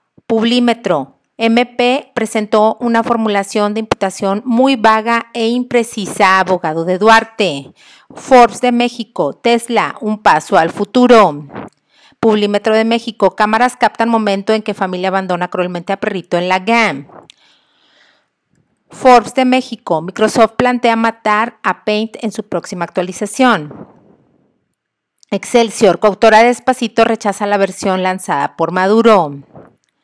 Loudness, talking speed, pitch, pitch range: -13 LUFS, 120 wpm, 220 Hz, 195-235 Hz